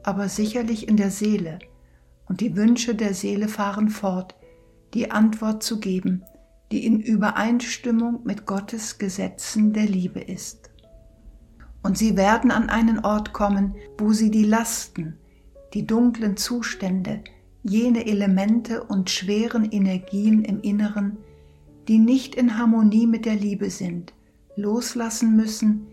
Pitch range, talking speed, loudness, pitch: 200-225 Hz, 130 wpm, -22 LUFS, 215 Hz